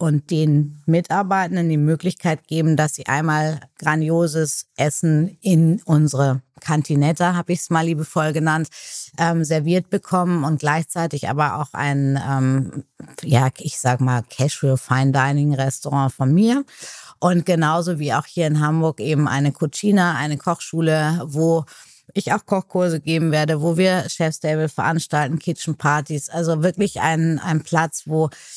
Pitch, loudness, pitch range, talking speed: 155 Hz, -20 LUFS, 145-170 Hz, 145 wpm